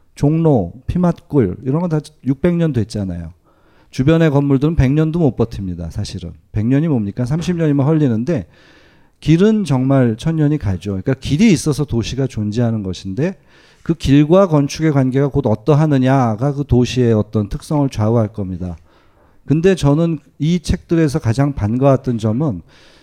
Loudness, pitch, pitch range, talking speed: -16 LUFS, 135 Hz, 110-155 Hz, 310 characters per minute